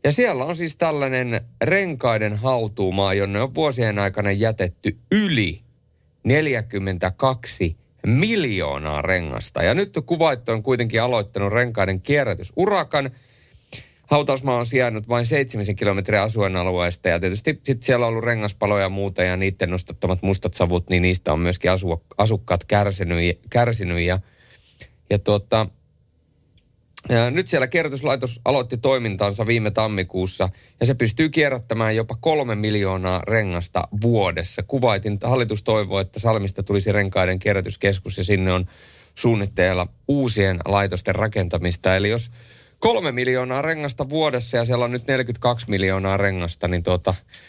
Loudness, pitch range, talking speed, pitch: -21 LUFS, 95-125 Hz, 130 wpm, 105 Hz